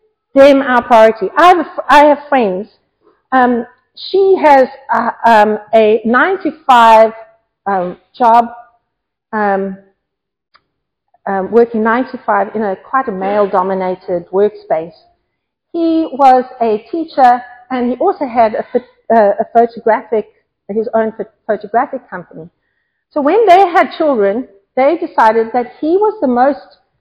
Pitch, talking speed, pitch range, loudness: 235 Hz, 125 wpm, 210-275 Hz, -12 LUFS